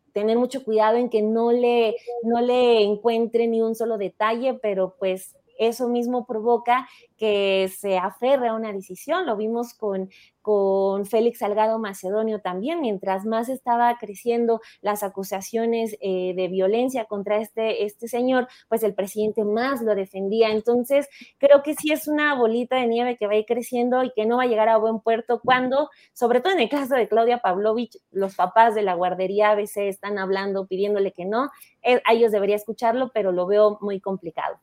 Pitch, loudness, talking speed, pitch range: 225 Hz, -22 LUFS, 185 wpm, 205-240 Hz